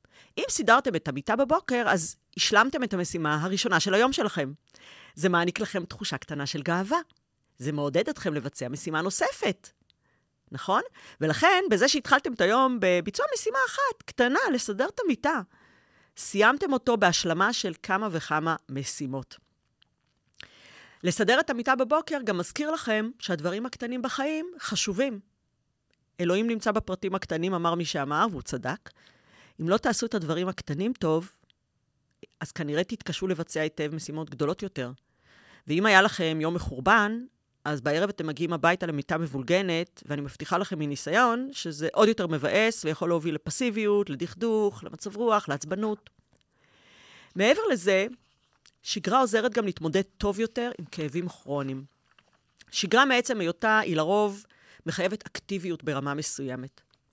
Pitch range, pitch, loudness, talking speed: 155-225 Hz, 185 Hz, -27 LUFS, 135 wpm